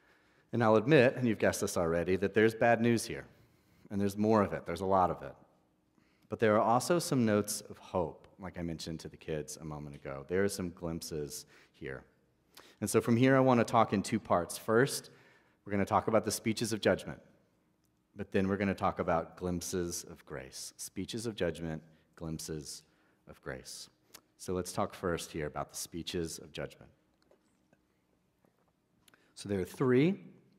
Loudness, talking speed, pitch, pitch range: -32 LUFS, 190 wpm, 95 Hz, 80-110 Hz